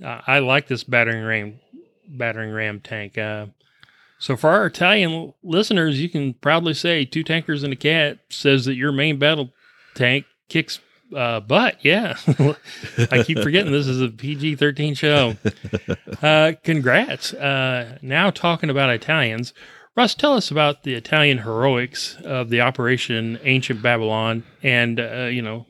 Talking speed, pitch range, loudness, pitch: 150 wpm, 120-155 Hz, -19 LUFS, 135 Hz